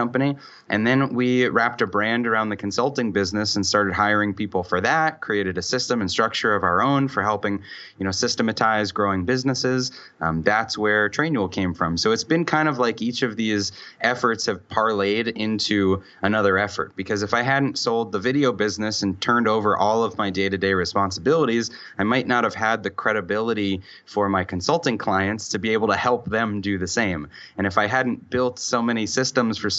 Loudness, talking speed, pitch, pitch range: -22 LUFS, 200 wpm, 105 Hz, 100-120 Hz